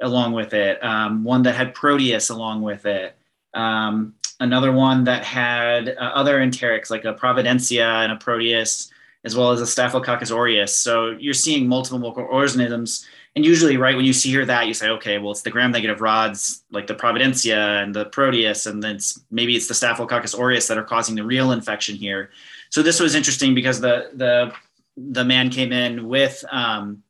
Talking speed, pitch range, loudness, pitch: 190 wpm, 110-130 Hz, -19 LUFS, 120 Hz